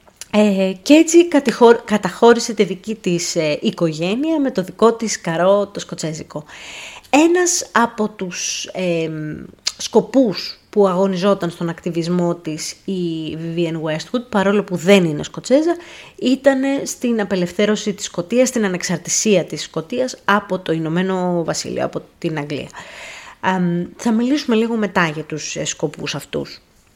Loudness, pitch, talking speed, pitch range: -18 LUFS, 195 Hz, 135 wpm, 170-230 Hz